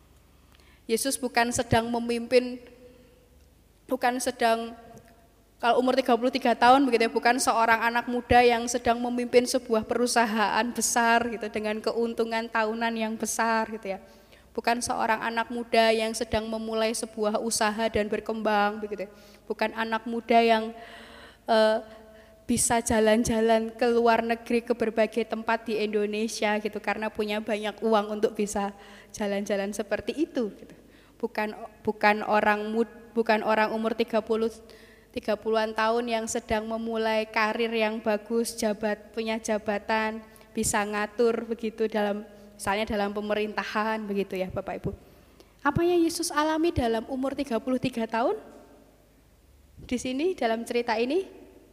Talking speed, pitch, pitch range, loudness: 125 wpm, 225 Hz, 215-235 Hz, -26 LUFS